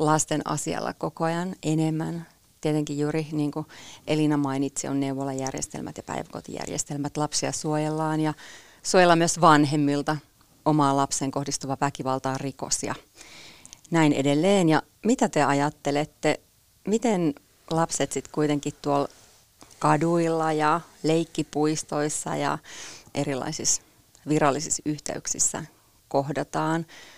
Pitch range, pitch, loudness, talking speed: 140-155 Hz, 150 Hz, -25 LUFS, 100 wpm